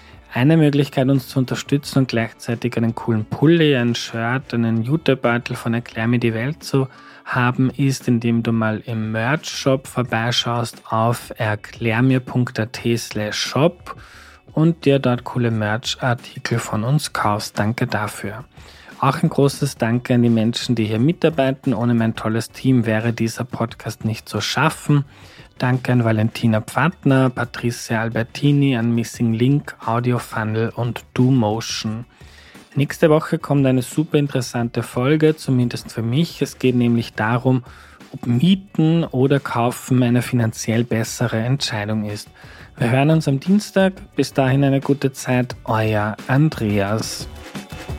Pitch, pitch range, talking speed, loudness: 120 Hz, 115-135 Hz, 140 wpm, -19 LUFS